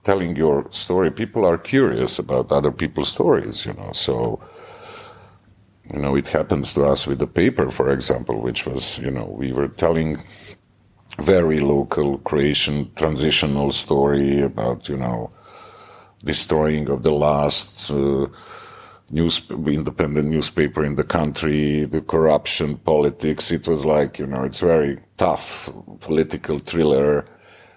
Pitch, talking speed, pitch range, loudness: 75 Hz, 135 wpm, 70-80 Hz, -20 LUFS